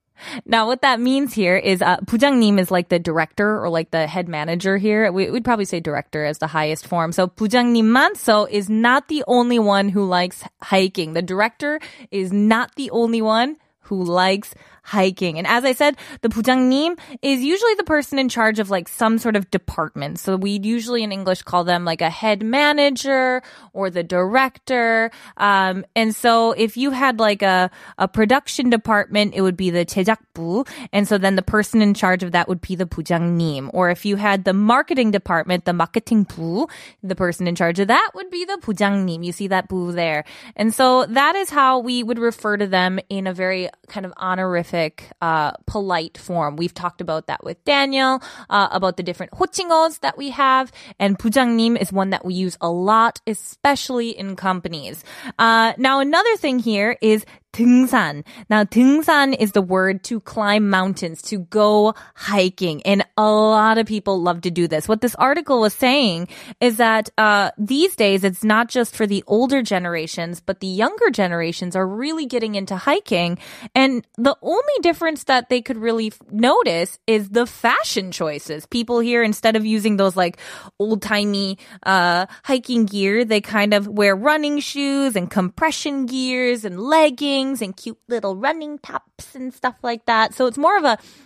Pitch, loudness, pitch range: 215 Hz, -19 LUFS, 185-250 Hz